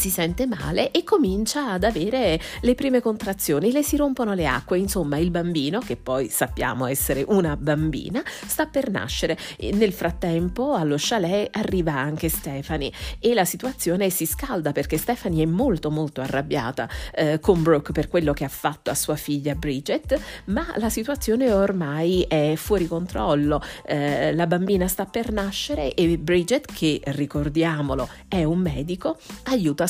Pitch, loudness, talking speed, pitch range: 175 Hz, -23 LUFS, 160 wpm, 150-215 Hz